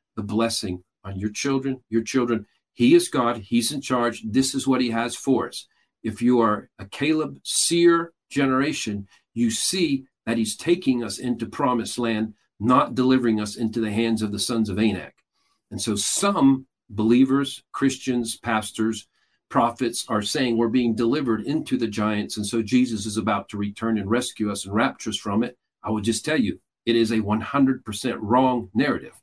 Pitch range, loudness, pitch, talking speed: 110-130 Hz, -23 LUFS, 115 Hz, 180 wpm